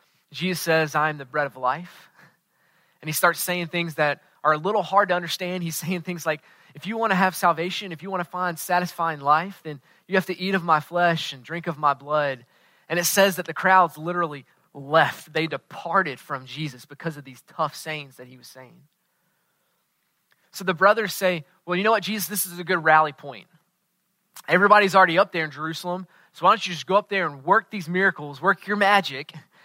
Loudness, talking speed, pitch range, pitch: -23 LUFS, 215 wpm, 155-185 Hz, 175 Hz